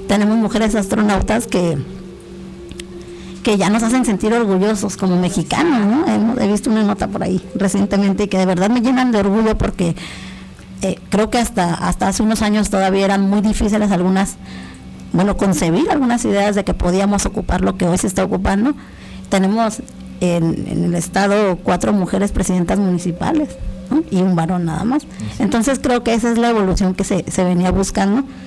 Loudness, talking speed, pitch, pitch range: -16 LUFS, 175 wpm, 195 Hz, 180-215 Hz